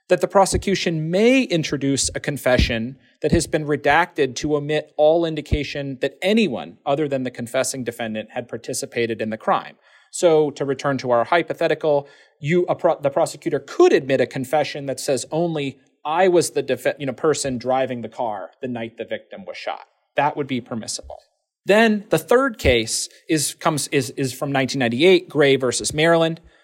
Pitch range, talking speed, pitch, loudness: 130-165 Hz, 175 wpm, 145 Hz, -20 LUFS